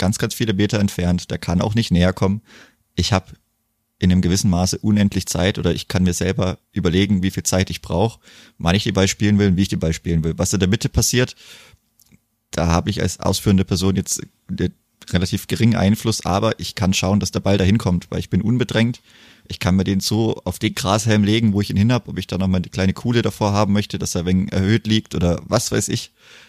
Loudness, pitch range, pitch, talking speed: -19 LUFS, 90-110 Hz, 100 Hz, 240 wpm